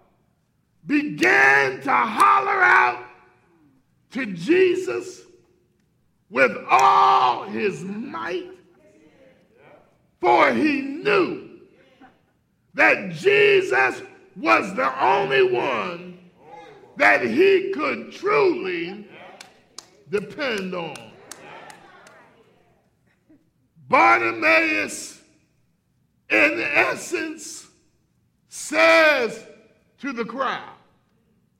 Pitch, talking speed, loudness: 305 Hz, 60 wpm, -19 LUFS